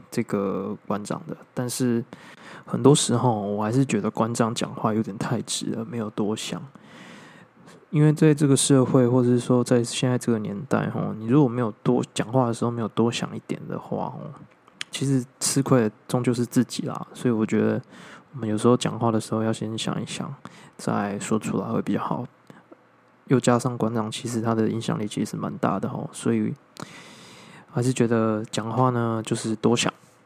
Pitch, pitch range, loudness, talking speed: 120 Hz, 110-130 Hz, -24 LUFS, 275 characters per minute